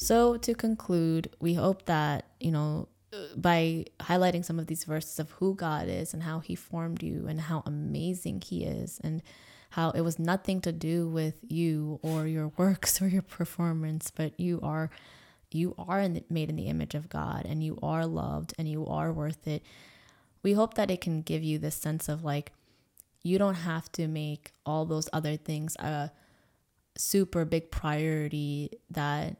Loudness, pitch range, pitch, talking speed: -31 LUFS, 155-170 Hz, 160 Hz, 185 wpm